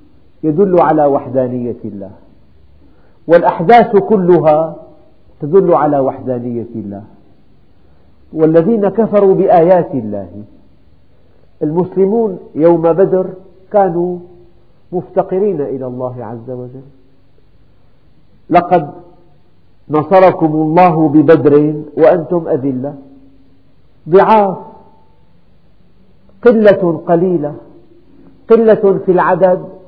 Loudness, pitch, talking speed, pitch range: -11 LUFS, 155 Hz, 70 wpm, 115-185 Hz